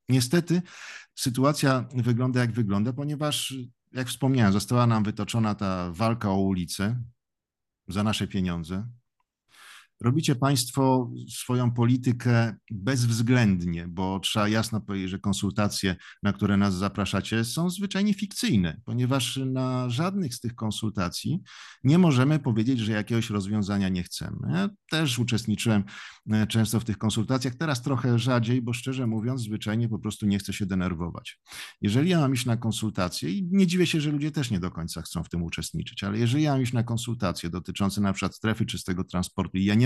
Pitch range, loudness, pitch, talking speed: 100-130 Hz, -26 LUFS, 115 Hz, 160 wpm